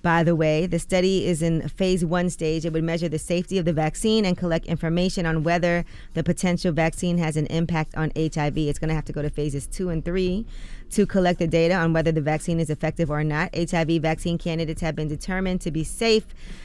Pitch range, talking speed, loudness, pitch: 160-180 Hz, 225 wpm, -24 LUFS, 165 Hz